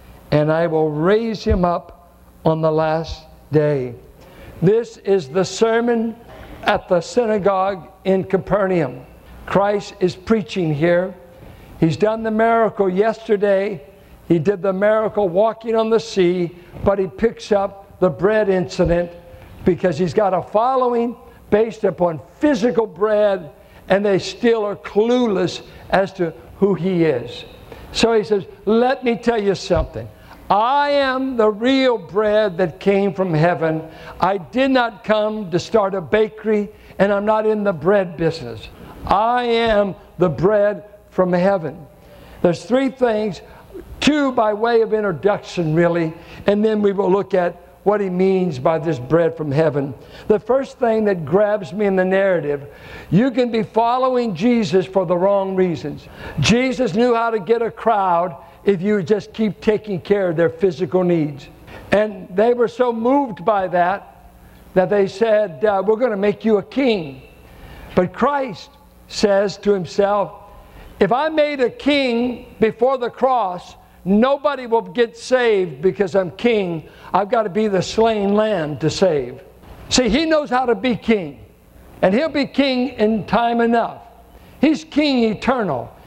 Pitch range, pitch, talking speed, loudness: 180-230 Hz, 205 Hz, 155 wpm, -18 LUFS